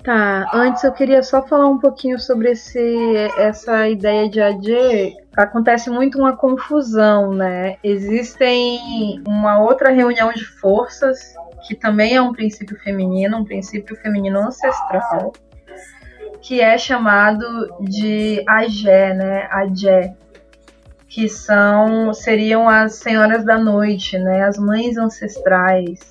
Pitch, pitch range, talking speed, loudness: 220 Hz, 205-240 Hz, 120 wpm, -15 LUFS